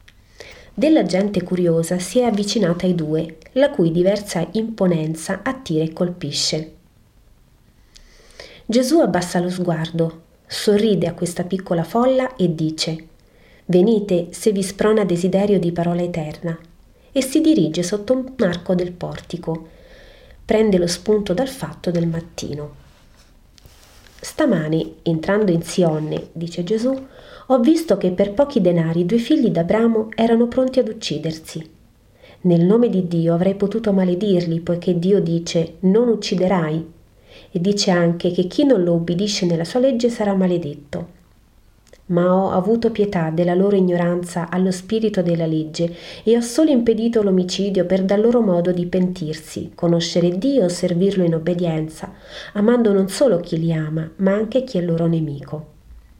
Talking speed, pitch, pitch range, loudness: 145 wpm, 180 Hz, 170-215 Hz, -19 LUFS